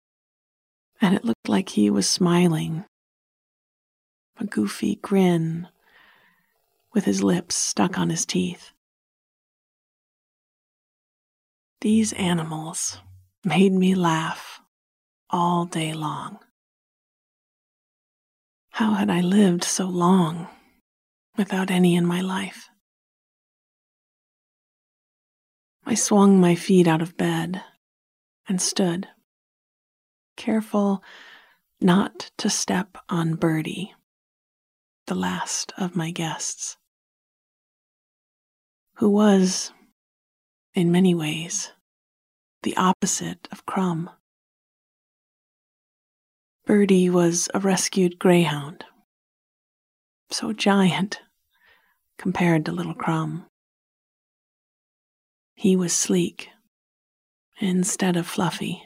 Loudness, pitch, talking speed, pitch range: -22 LUFS, 180 Hz, 85 wpm, 165-195 Hz